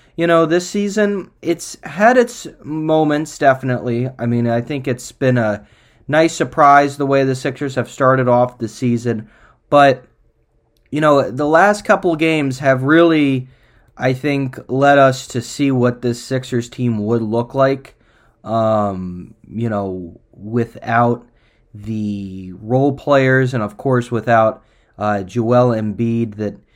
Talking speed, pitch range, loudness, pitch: 145 wpm, 115-145 Hz, -16 LUFS, 125 Hz